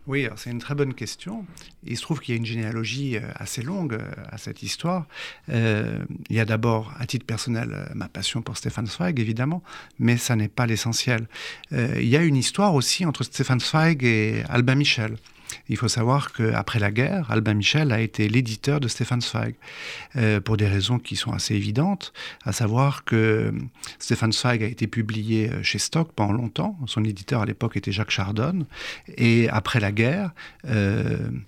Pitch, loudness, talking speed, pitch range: 120 Hz, -24 LUFS, 185 wpm, 110-140 Hz